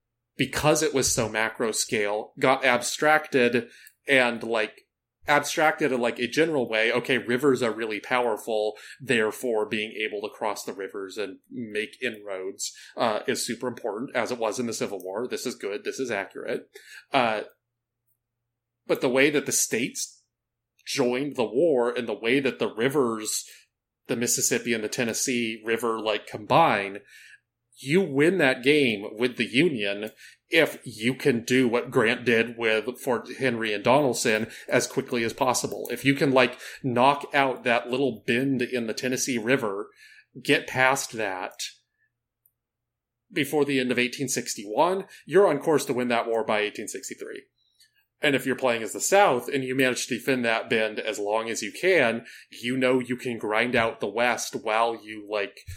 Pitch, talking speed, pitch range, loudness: 120 Hz, 165 wpm, 115-135 Hz, -25 LUFS